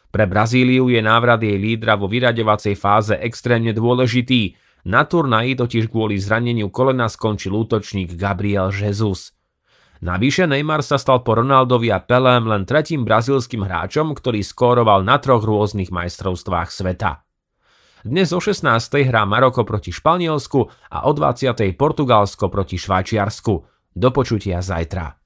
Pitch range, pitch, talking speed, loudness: 100-125 Hz, 110 Hz, 135 wpm, -18 LUFS